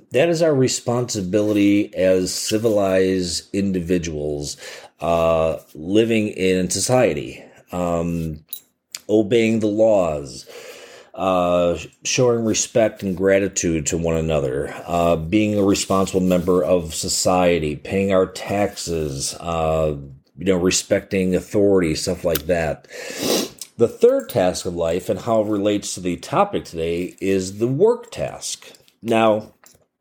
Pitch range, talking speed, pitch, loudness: 85-110 Hz, 120 wpm, 95 Hz, -20 LUFS